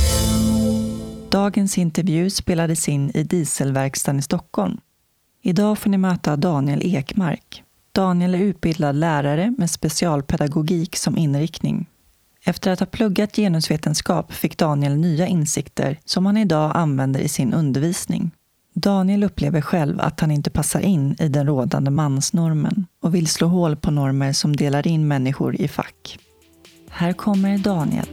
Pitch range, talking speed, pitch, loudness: 145-185 Hz, 140 wpm, 165 Hz, -20 LUFS